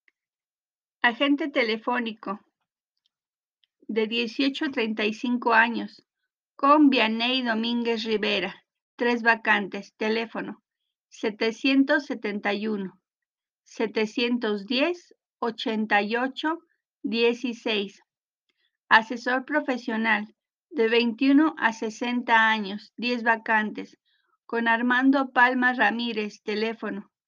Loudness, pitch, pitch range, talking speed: -24 LUFS, 235 Hz, 220-260 Hz, 70 wpm